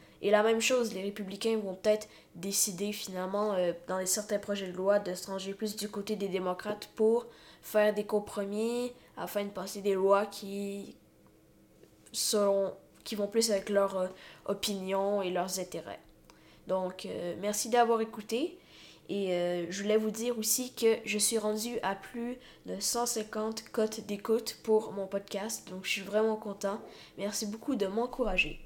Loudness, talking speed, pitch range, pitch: -32 LUFS, 165 wpm, 195-220 Hz, 205 Hz